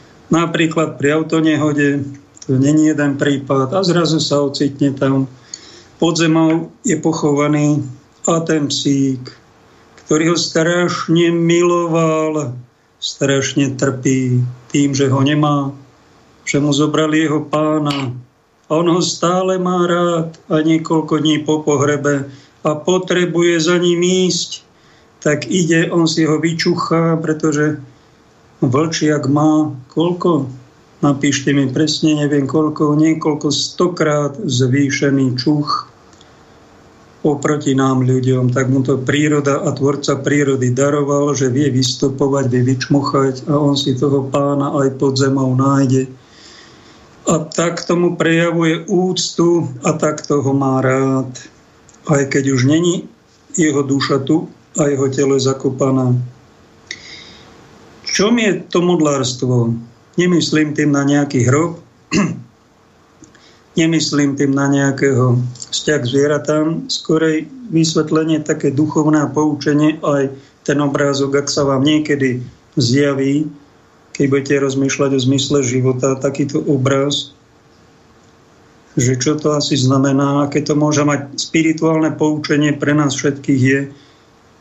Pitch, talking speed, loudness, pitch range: 145 Hz, 120 wpm, -15 LUFS, 140-155 Hz